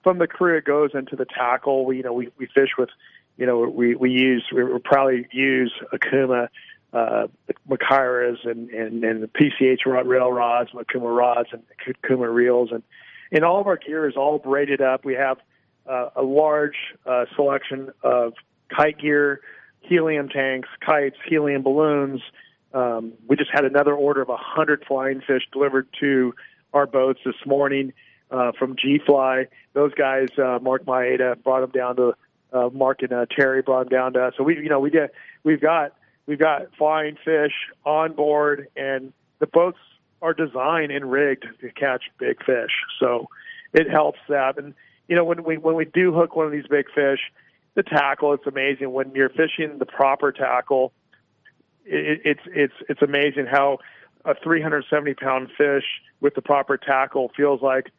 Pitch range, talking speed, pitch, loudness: 130-150 Hz, 180 wpm, 135 Hz, -21 LUFS